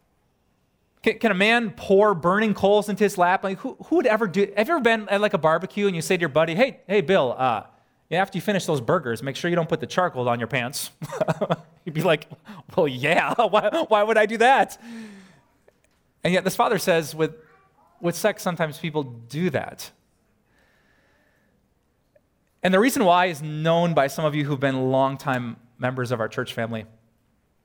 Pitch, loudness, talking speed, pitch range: 175 Hz, -22 LUFS, 195 wpm, 140-205 Hz